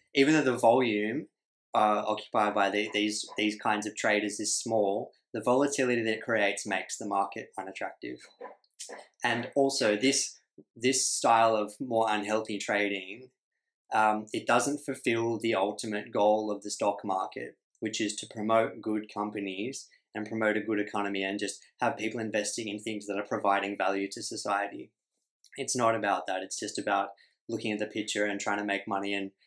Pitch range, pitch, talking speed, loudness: 105-115 Hz, 105 Hz, 175 wpm, -30 LUFS